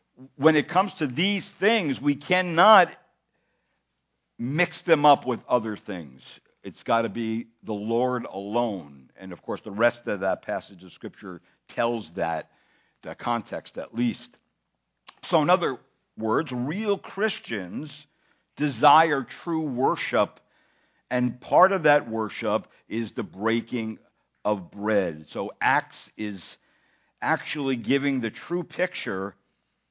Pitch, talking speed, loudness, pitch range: 125 Hz, 130 wpm, -25 LUFS, 110-155 Hz